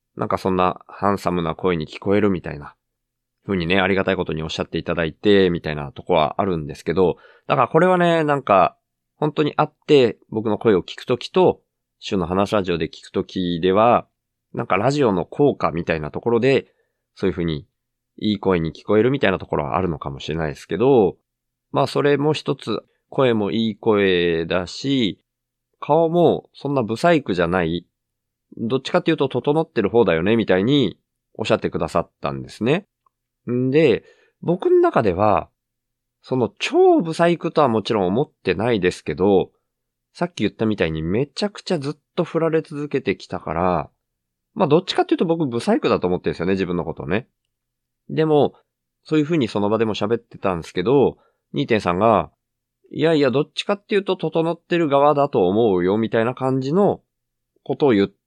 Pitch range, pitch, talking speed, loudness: 90-150 Hz, 110 Hz, 370 characters per minute, -20 LUFS